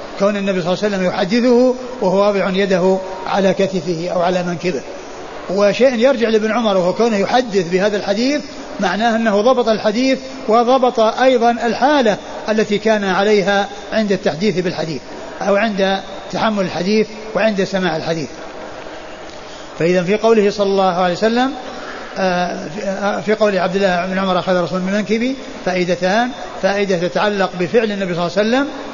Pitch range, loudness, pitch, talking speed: 185-230 Hz, -16 LUFS, 200 Hz, 145 wpm